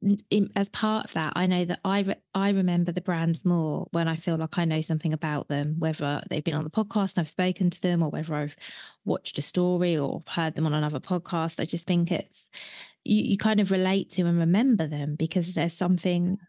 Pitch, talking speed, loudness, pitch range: 175 Hz, 225 wpm, -27 LUFS, 160-190 Hz